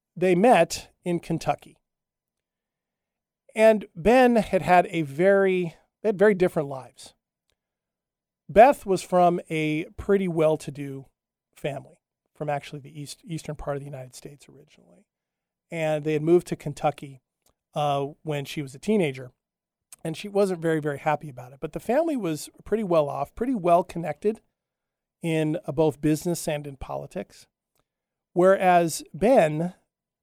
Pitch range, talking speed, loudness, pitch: 150-185 Hz, 145 wpm, -24 LUFS, 160 Hz